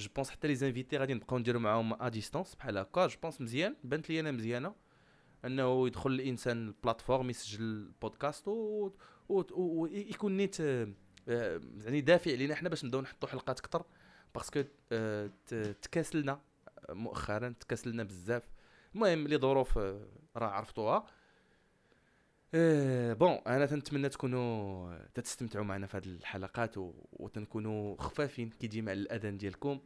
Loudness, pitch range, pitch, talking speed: -36 LUFS, 110-145 Hz, 125 Hz, 130 wpm